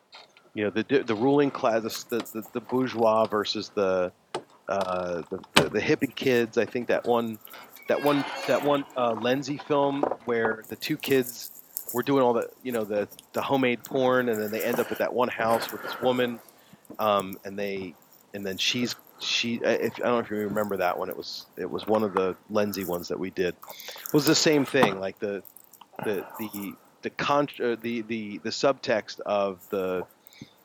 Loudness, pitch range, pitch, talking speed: -27 LUFS, 100-125 Hz, 115 Hz, 200 wpm